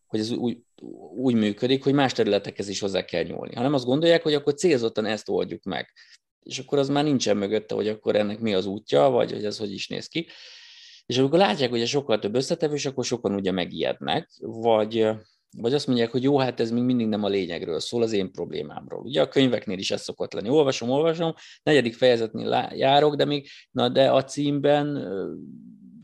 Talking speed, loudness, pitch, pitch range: 205 wpm, -24 LUFS, 125 Hz, 110-145 Hz